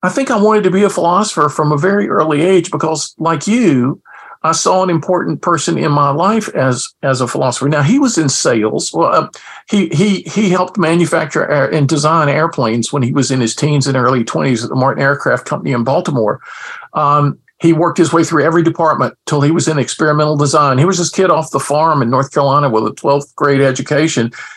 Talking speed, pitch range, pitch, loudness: 215 wpm, 140-170 Hz, 150 Hz, -13 LUFS